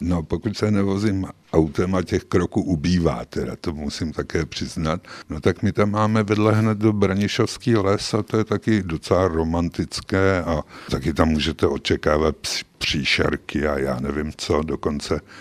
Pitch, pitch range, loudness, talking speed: 95 Hz, 80-105 Hz, -22 LUFS, 160 wpm